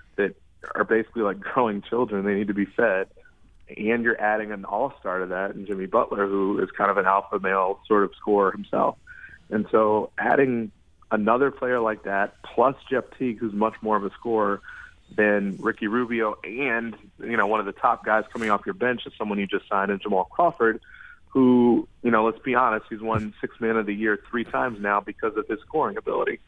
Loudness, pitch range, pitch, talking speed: -24 LUFS, 100-120 Hz, 110 Hz, 210 wpm